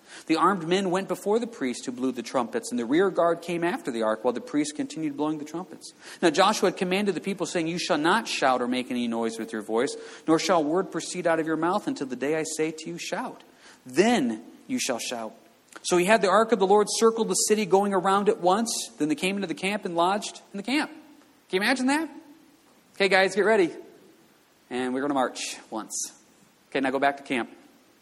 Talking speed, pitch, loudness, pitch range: 235 wpm, 190 Hz, -25 LUFS, 155-240 Hz